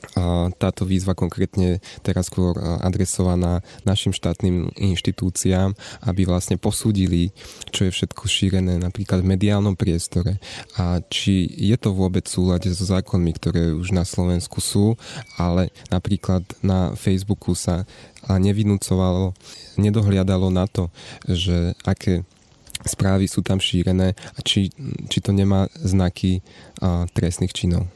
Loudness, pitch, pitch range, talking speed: -21 LUFS, 95 Hz, 90-100 Hz, 120 wpm